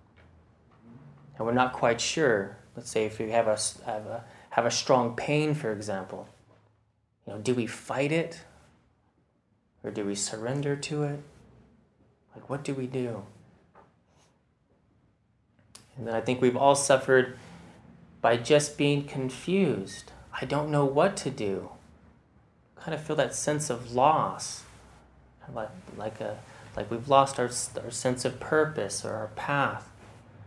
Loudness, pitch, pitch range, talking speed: -28 LUFS, 120 Hz, 110-140 Hz, 150 wpm